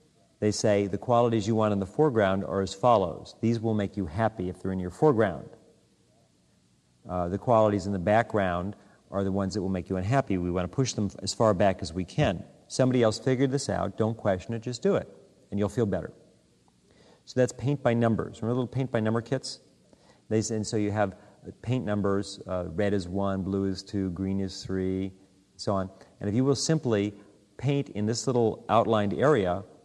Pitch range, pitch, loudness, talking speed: 95-115 Hz, 105 Hz, -28 LUFS, 205 wpm